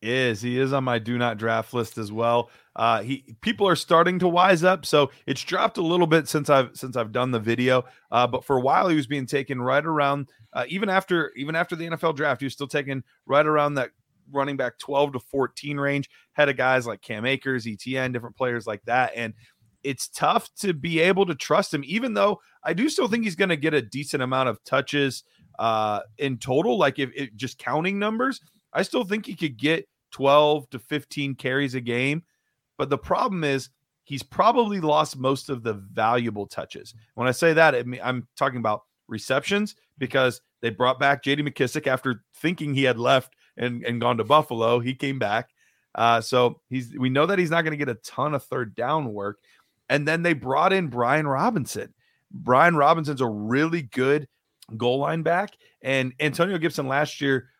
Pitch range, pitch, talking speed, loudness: 125-155 Hz, 135 Hz, 205 wpm, -24 LUFS